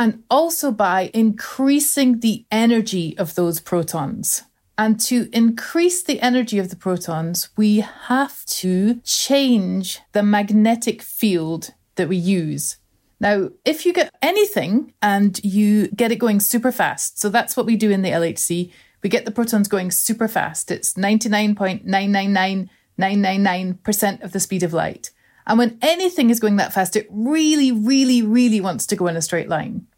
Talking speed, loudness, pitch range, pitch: 160 wpm, -19 LUFS, 190-235 Hz, 210 Hz